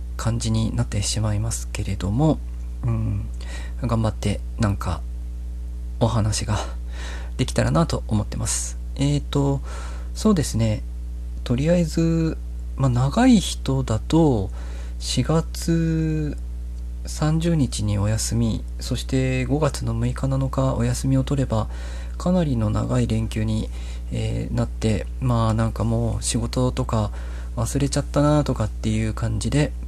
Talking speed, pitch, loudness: 245 characters per minute, 110 Hz, -23 LUFS